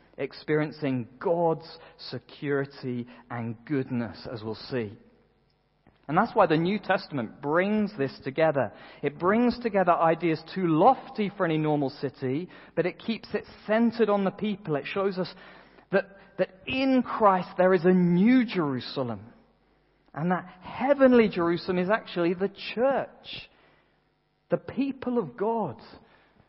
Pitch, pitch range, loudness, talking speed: 180 Hz, 145-210 Hz, -27 LUFS, 135 wpm